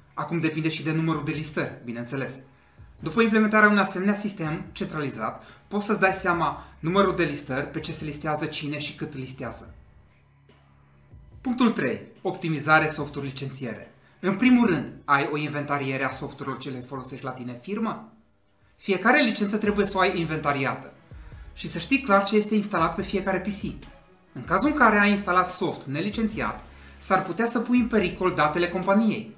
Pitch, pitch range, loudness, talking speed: 160 Hz, 140-200 Hz, -25 LUFS, 165 wpm